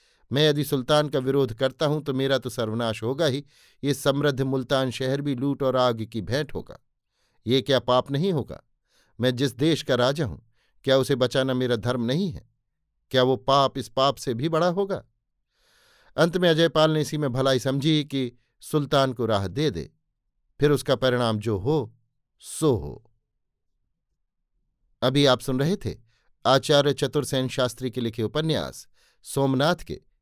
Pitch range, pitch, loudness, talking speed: 125-145 Hz, 135 Hz, -24 LUFS, 170 wpm